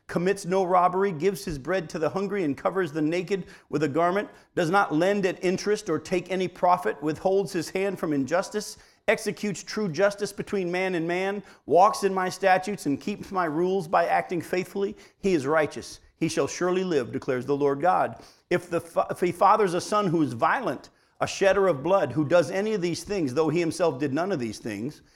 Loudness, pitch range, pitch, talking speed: -26 LUFS, 165-195 Hz, 185 Hz, 210 wpm